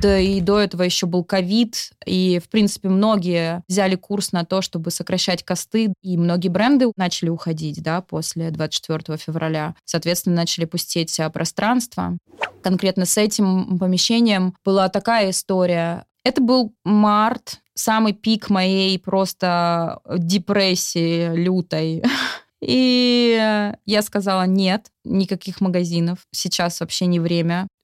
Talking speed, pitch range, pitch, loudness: 125 wpm, 170-205 Hz, 185 Hz, -20 LUFS